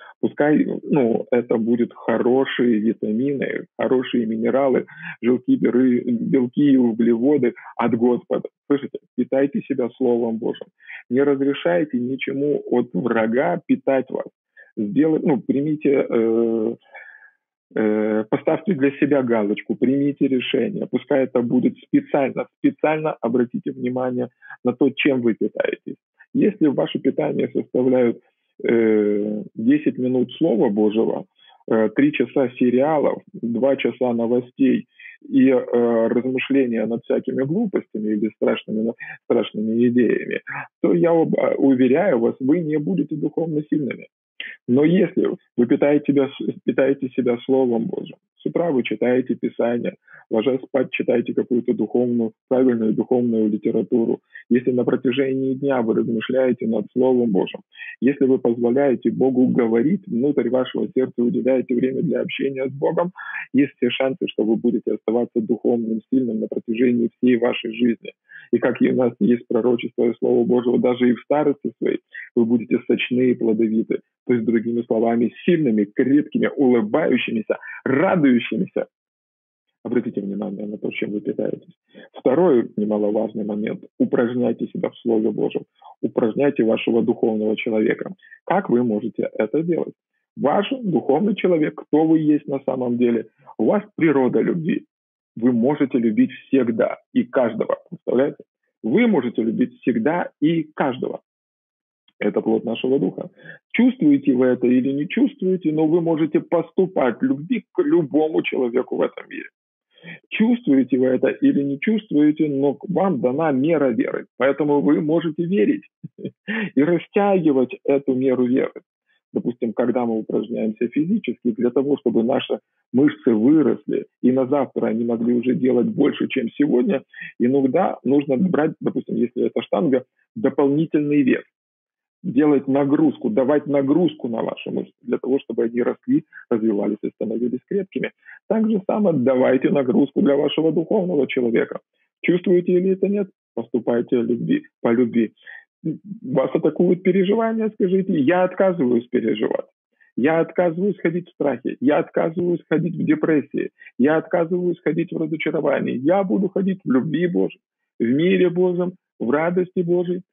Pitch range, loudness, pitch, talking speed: 120-165 Hz, -20 LUFS, 130 Hz, 135 wpm